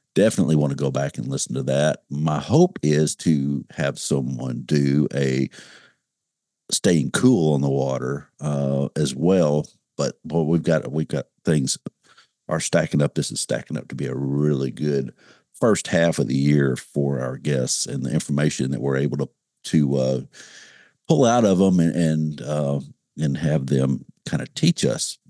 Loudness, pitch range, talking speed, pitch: -22 LUFS, 70-75 Hz, 180 wpm, 70 Hz